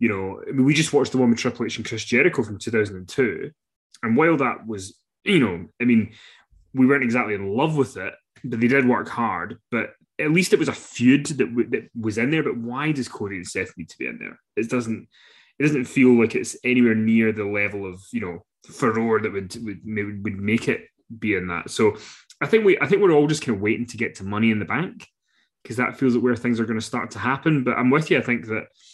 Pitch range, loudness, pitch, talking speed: 110-130 Hz, -22 LUFS, 115 Hz, 255 wpm